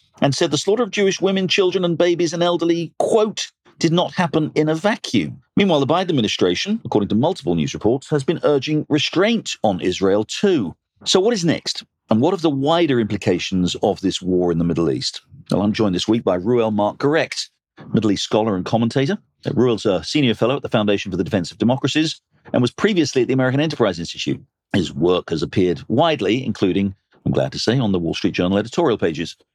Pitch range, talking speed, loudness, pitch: 105-170 Hz, 210 wpm, -19 LUFS, 135 Hz